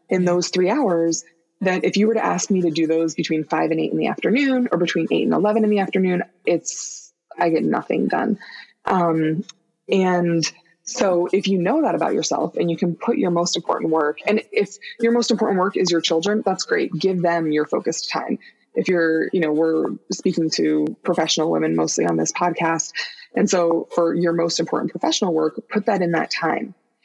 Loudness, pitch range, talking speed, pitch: -20 LUFS, 165-190 Hz, 205 wpm, 175 Hz